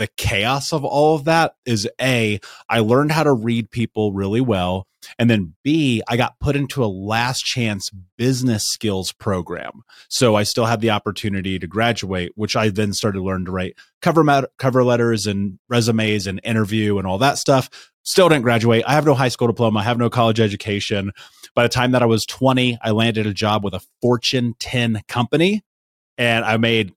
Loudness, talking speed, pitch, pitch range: -19 LUFS, 200 wpm, 115 Hz, 105-125 Hz